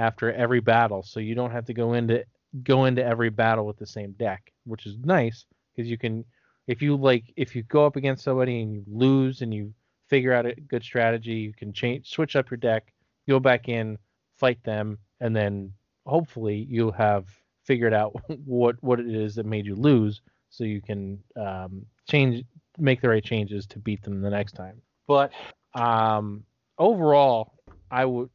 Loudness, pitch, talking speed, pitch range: -25 LUFS, 115 Hz, 190 wpm, 105-130 Hz